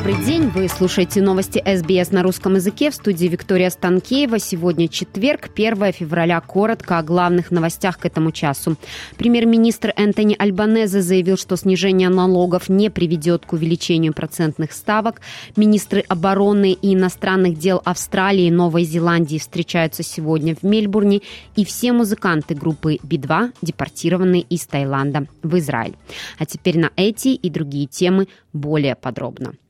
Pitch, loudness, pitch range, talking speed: 180 Hz, -18 LUFS, 165-200 Hz, 140 wpm